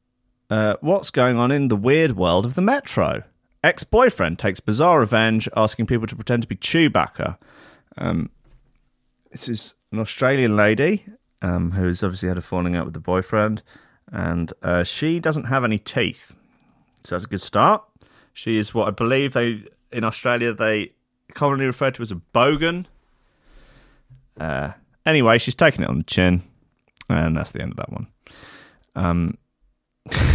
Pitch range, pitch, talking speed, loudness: 95-135 Hz, 115 Hz, 160 wpm, -21 LUFS